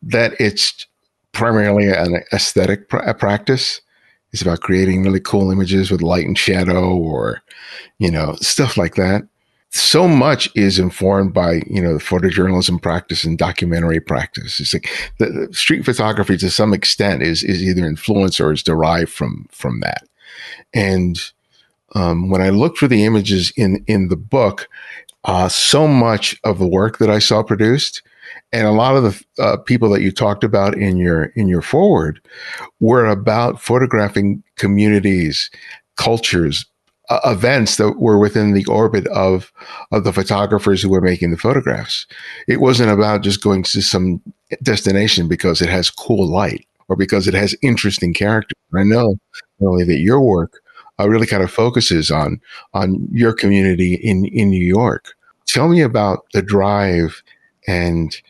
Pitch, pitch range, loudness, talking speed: 100 Hz, 90-110 Hz, -15 LUFS, 165 wpm